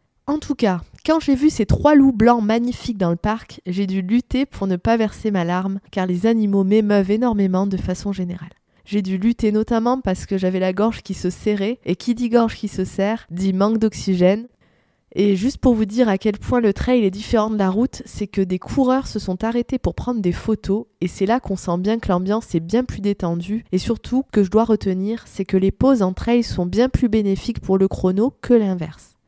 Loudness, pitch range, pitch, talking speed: -20 LUFS, 190-235 Hz, 210 Hz, 230 wpm